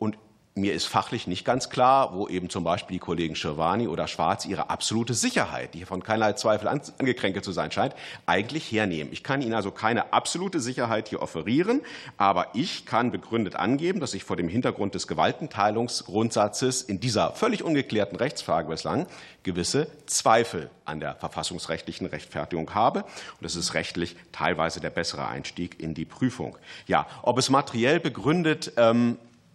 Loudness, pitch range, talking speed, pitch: -26 LUFS, 85-120 Hz, 160 wpm, 105 Hz